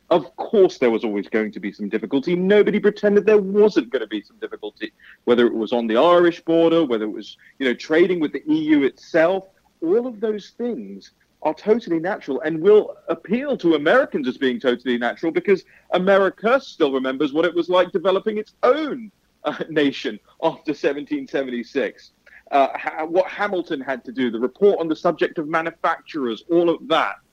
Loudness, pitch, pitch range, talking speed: -20 LUFS, 175 Hz, 140-210 Hz, 185 wpm